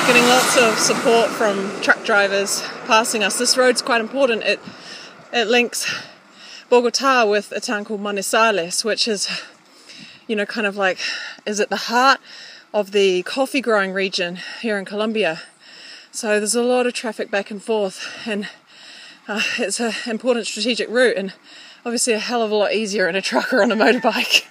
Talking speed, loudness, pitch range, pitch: 175 wpm, -19 LUFS, 205-245 Hz, 225 Hz